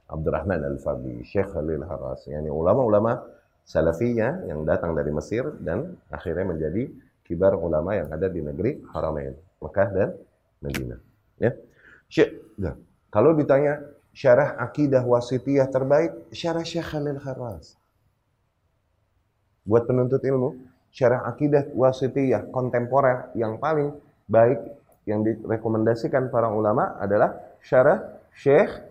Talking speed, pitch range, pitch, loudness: 110 wpm, 100-135 Hz, 115 Hz, -24 LUFS